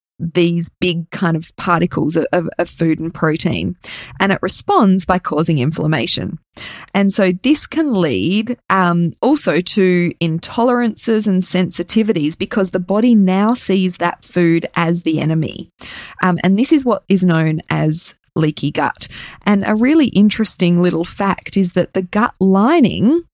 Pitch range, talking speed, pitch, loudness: 165-205 Hz, 150 wpm, 185 Hz, -15 LUFS